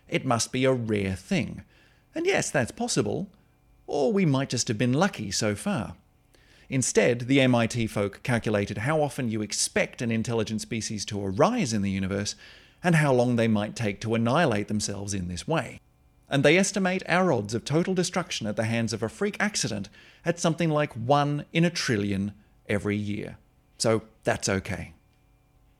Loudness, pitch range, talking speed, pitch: -26 LUFS, 105-150 Hz, 175 wpm, 115 Hz